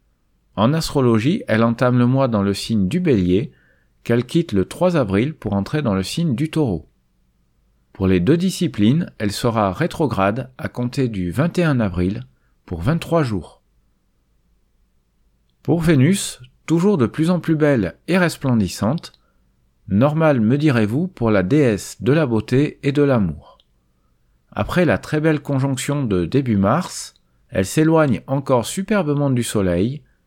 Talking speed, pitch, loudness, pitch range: 145 wpm, 125 Hz, -19 LUFS, 95-155 Hz